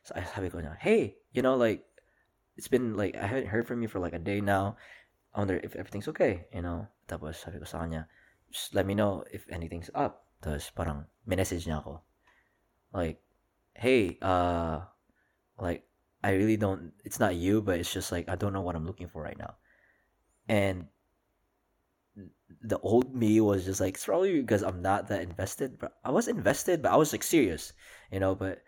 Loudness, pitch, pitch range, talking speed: -31 LUFS, 95 Hz, 85-100 Hz, 175 wpm